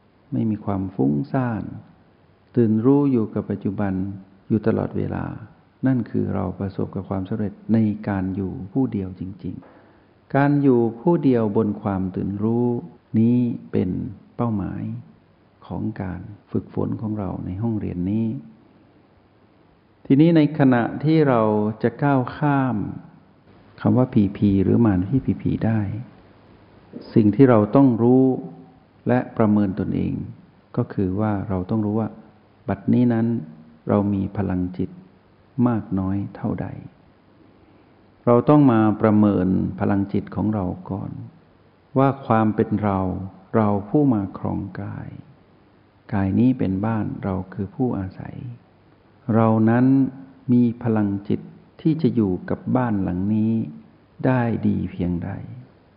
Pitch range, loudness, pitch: 95-120 Hz, -21 LUFS, 105 Hz